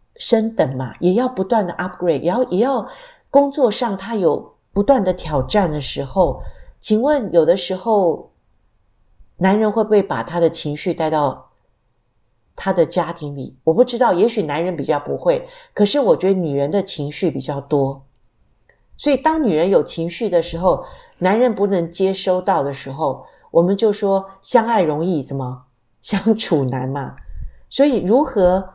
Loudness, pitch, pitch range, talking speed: -18 LUFS, 185 Hz, 145-225 Hz, 250 characters per minute